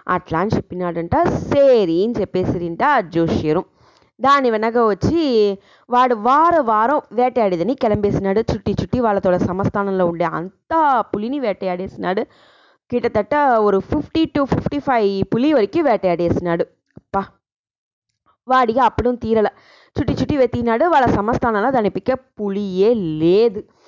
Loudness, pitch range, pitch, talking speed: -18 LUFS, 195-260 Hz, 220 Hz, 105 wpm